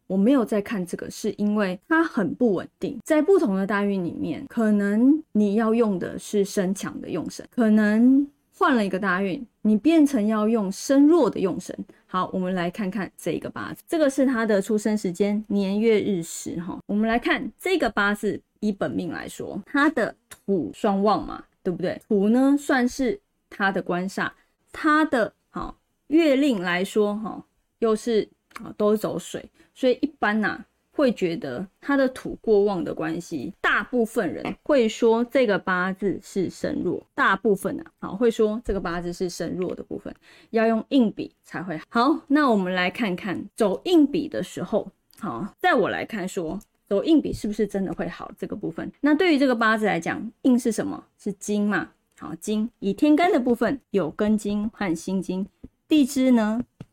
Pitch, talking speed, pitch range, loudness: 215 Hz, 260 characters per minute, 195-265 Hz, -23 LUFS